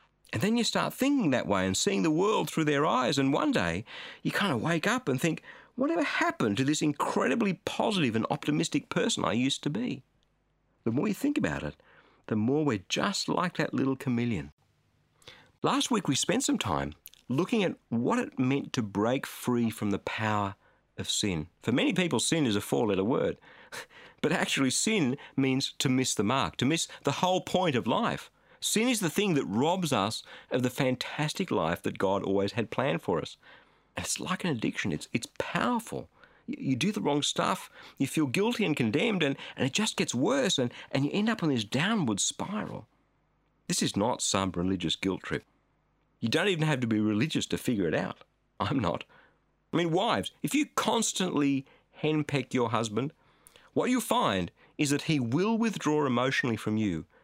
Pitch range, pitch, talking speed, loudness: 125-210 Hz, 145 Hz, 195 wpm, -29 LUFS